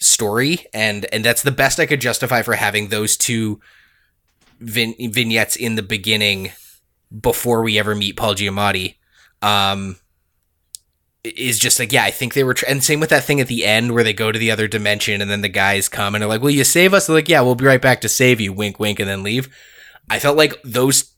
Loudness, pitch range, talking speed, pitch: -16 LUFS, 105-125 Hz, 225 wpm, 110 Hz